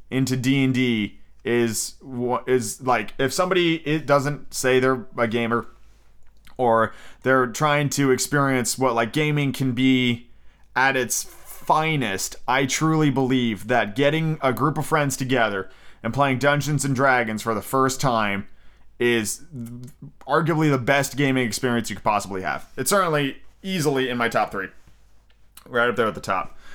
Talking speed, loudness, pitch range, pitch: 155 wpm, -22 LUFS, 115-140 Hz, 130 Hz